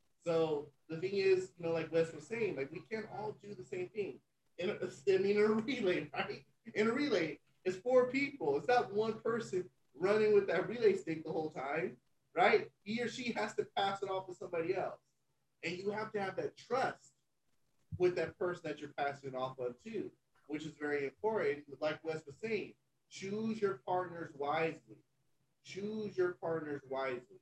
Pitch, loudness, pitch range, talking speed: 180 Hz, -37 LUFS, 155-215 Hz, 190 wpm